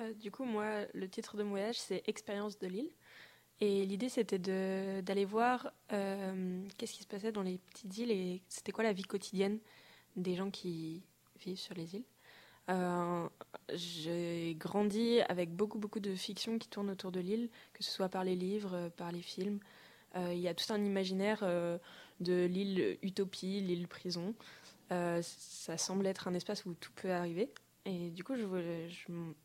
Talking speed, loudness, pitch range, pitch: 185 wpm, -39 LUFS, 180-210 Hz, 195 Hz